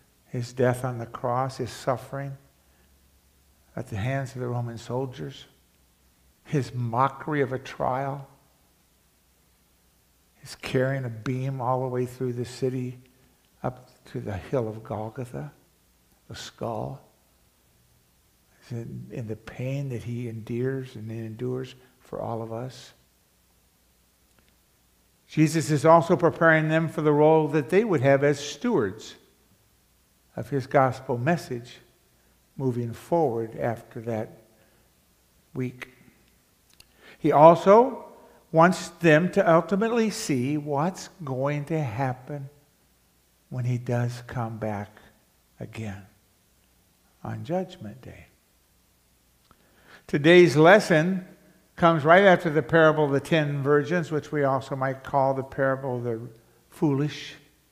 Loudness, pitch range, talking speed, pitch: -24 LUFS, 110-145 Hz, 115 wpm, 130 Hz